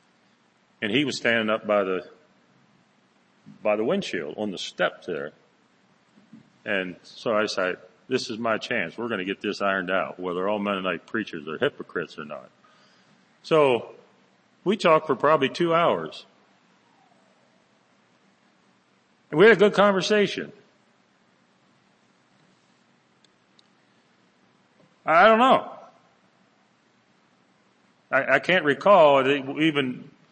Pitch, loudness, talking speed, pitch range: 115 Hz, -23 LUFS, 115 wpm, 95-155 Hz